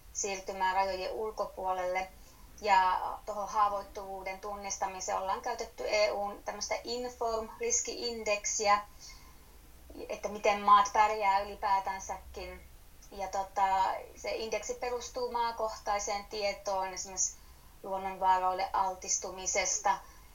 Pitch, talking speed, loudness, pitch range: 195 Hz, 80 wpm, -32 LUFS, 190-210 Hz